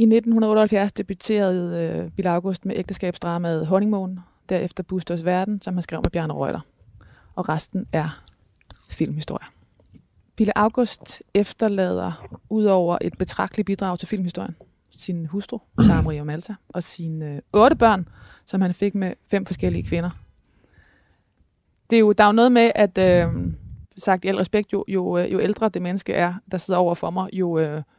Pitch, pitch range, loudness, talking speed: 185 Hz, 160-200 Hz, -22 LUFS, 165 wpm